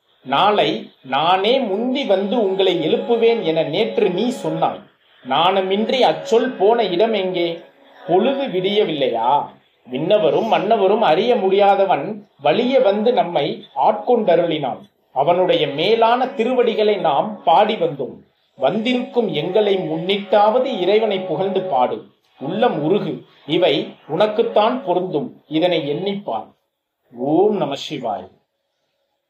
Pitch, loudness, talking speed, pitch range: 200 Hz, -18 LUFS, 95 wpm, 180-230 Hz